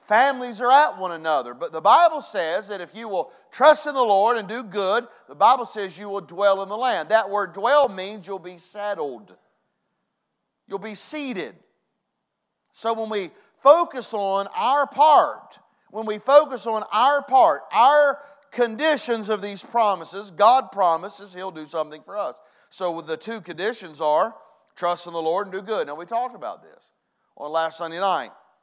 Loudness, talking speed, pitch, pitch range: -21 LUFS, 180 wpm, 210 Hz, 190-255 Hz